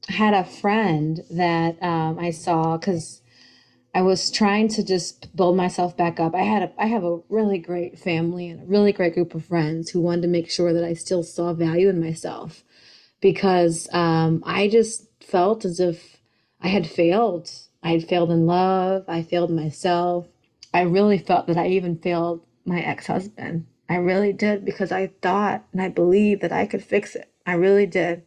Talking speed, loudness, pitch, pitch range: 195 wpm, -22 LUFS, 175 Hz, 165-190 Hz